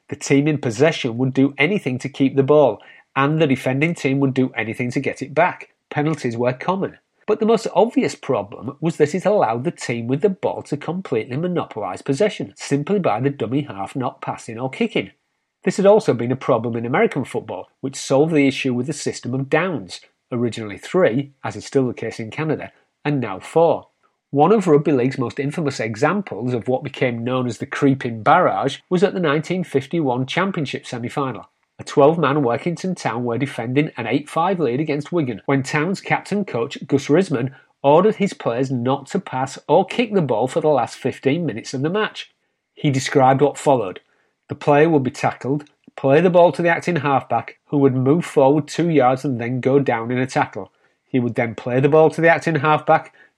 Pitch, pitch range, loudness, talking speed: 140 Hz, 130-160 Hz, -19 LUFS, 200 wpm